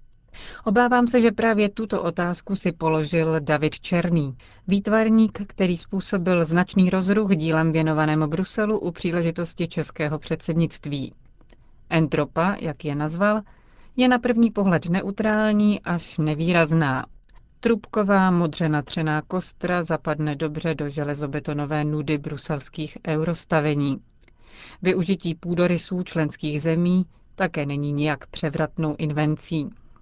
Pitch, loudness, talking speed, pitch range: 165 Hz, -23 LUFS, 105 wpm, 155-190 Hz